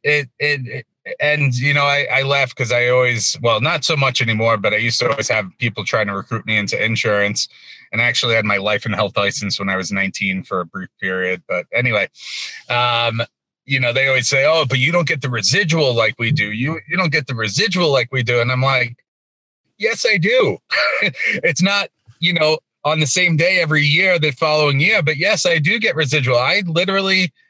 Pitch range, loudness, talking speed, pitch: 115-155 Hz, -16 LUFS, 220 wpm, 135 Hz